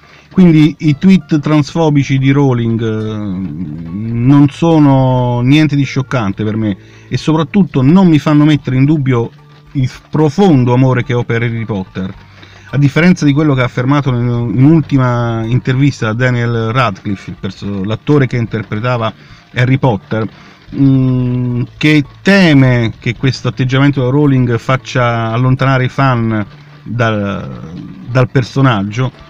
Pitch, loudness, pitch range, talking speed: 130 Hz, -12 LUFS, 115-145 Hz, 125 wpm